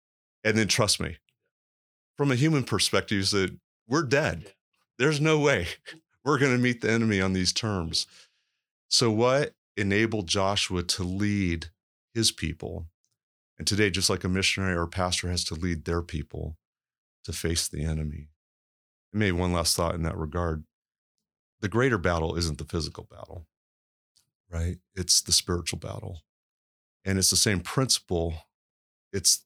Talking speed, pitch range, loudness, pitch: 155 wpm, 80-105 Hz, -26 LUFS, 90 Hz